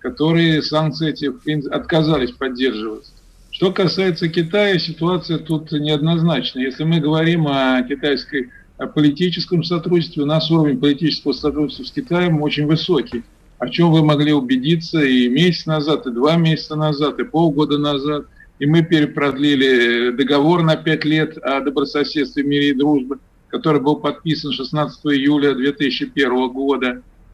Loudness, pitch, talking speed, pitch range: -17 LUFS, 150 Hz, 135 wpm, 140-160 Hz